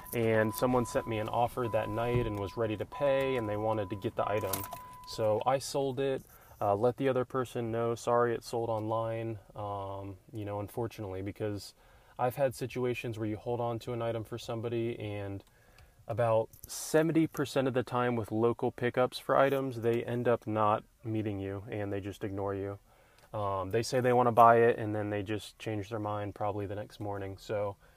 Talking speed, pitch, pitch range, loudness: 200 wpm, 115 Hz, 105-125 Hz, -32 LUFS